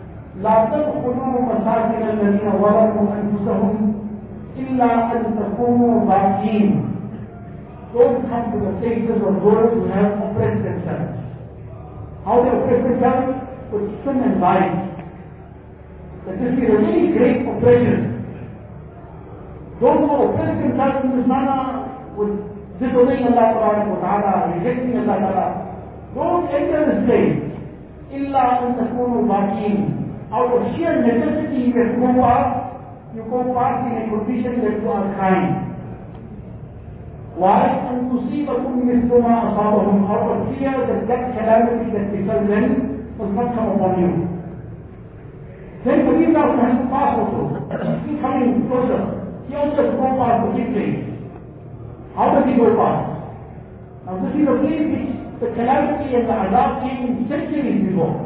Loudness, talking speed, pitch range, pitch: -18 LUFS, 130 wpm, 210-255 Hz, 235 Hz